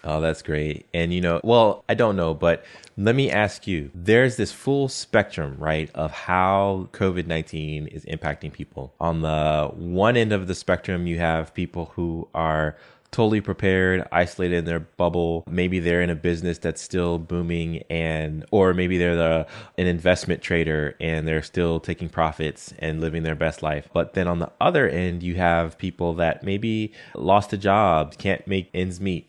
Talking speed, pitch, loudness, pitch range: 180 wpm, 85 Hz, -23 LUFS, 80-95 Hz